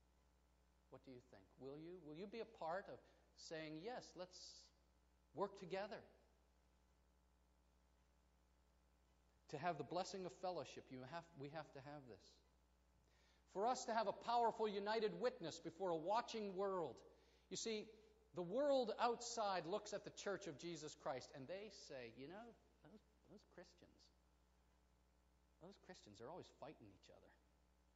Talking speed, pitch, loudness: 150 wpm, 145 Hz, -48 LUFS